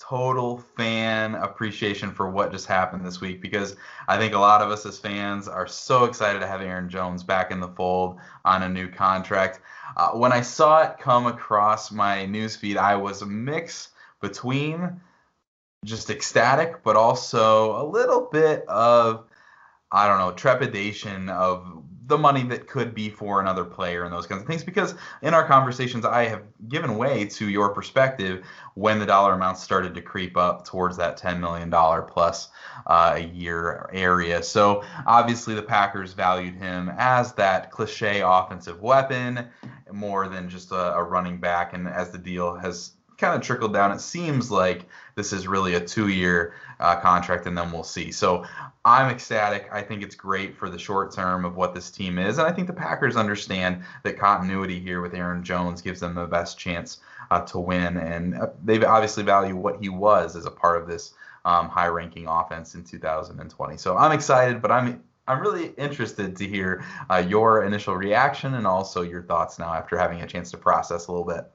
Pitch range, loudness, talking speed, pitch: 90-110 Hz, -23 LUFS, 190 wpm, 100 Hz